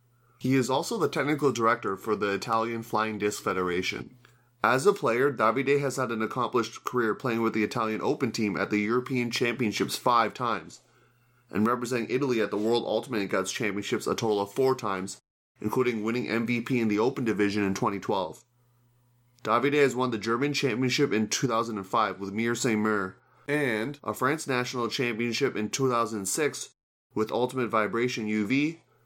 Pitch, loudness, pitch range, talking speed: 120 Hz, -27 LUFS, 110-130 Hz, 160 wpm